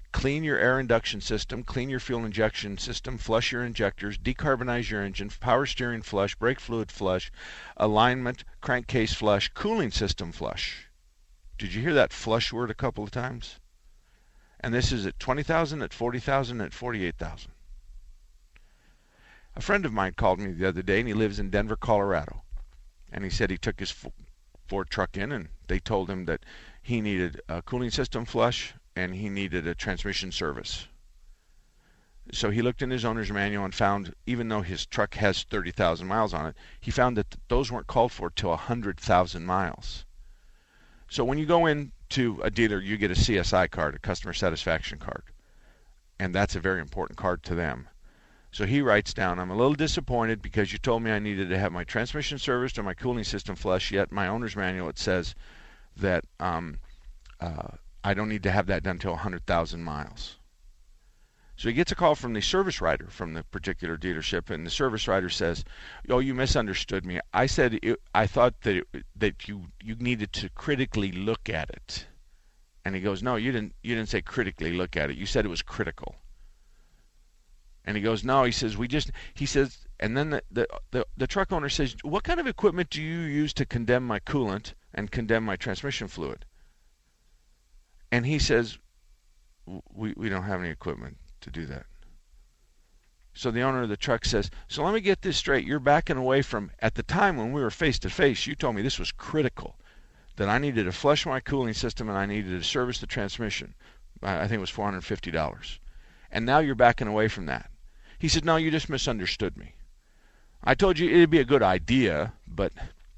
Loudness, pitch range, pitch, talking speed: -28 LUFS, 95-125 Hz, 105 Hz, 195 wpm